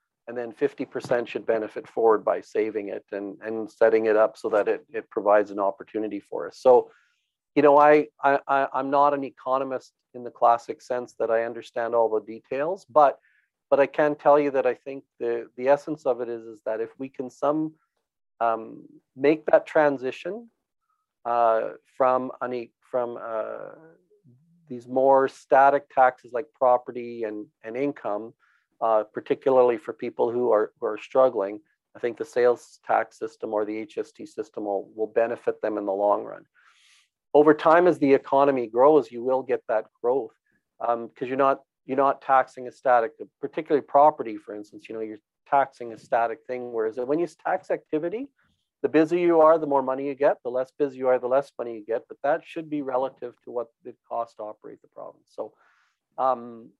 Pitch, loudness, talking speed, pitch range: 130 Hz, -24 LUFS, 190 wpm, 115-150 Hz